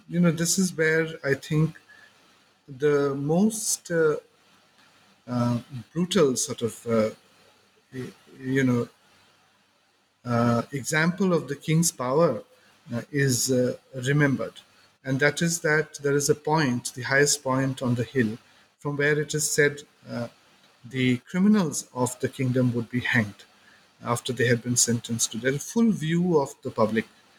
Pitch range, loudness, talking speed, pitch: 120-155 Hz, -25 LUFS, 145 wpm, 135 Hz